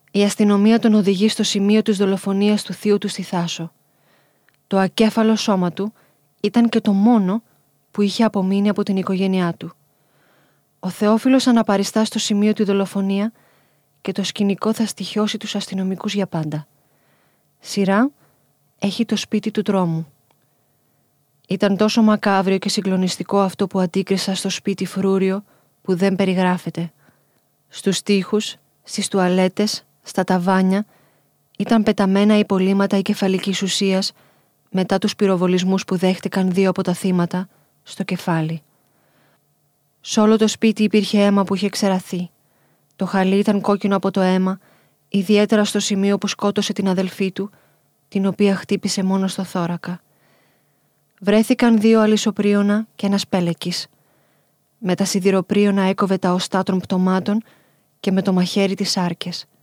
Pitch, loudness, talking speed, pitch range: 195 Hz, -19 LUFS, 140 wpm, 185-205 Hz